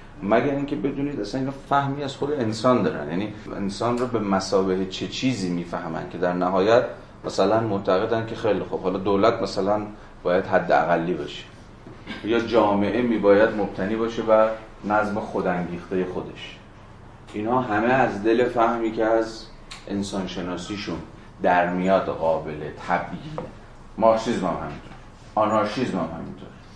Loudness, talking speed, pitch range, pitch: -23 LUFS, 140 wpm, 95-115 Hz, 105 Hz